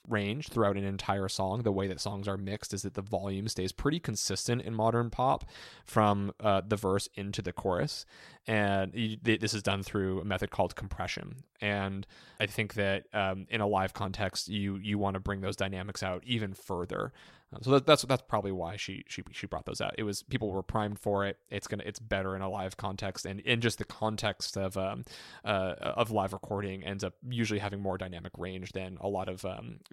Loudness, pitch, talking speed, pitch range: -33 LUFS, 100 Hz, 220 wpm, 95-110 Hz